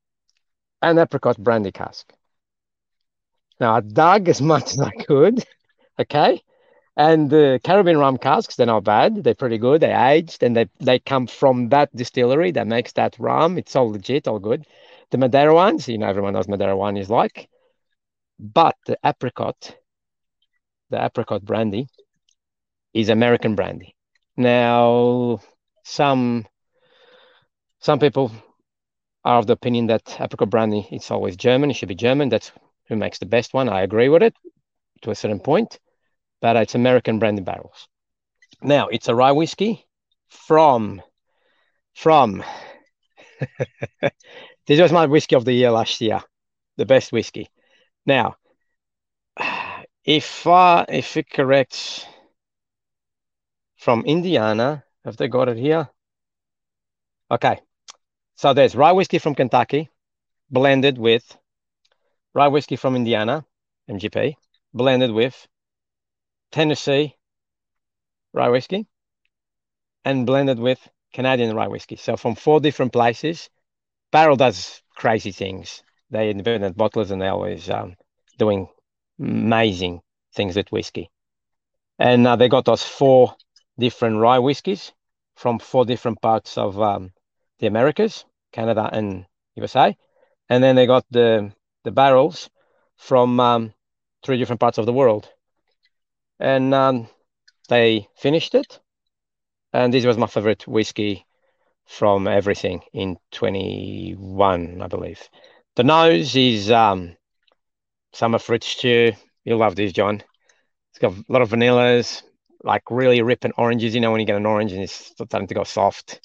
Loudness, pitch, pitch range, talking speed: -19 LUFS, 120 Hz, 110-140 Hz, 135 wpm